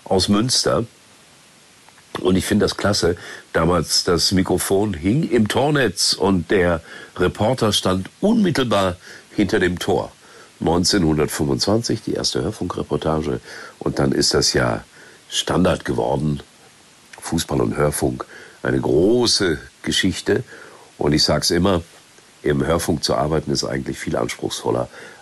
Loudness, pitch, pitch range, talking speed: -19 LUFS, 90 Hz, 75-100 Hz, 120 wpm